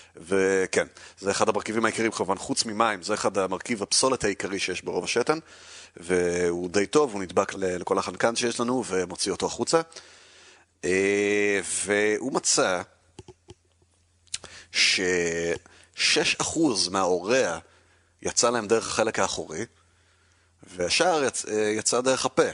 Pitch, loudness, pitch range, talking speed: 100 Hz, -25 LUFS, 90-115 Hz, 110 wpm